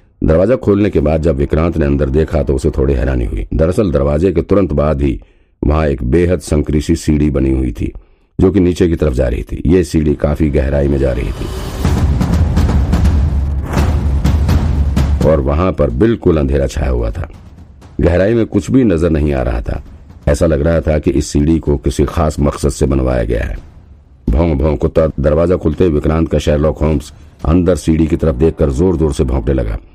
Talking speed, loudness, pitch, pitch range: 190 wpm, -14 LUFS, 75 Hz, 70-85 Hz